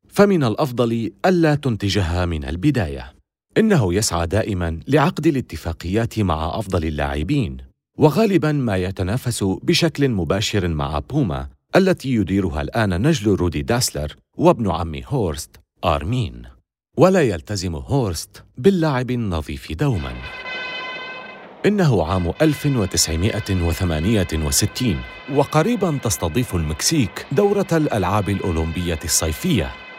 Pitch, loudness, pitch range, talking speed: 100 Hz, -20 LUFS, 85-140 Hz, 95 wpm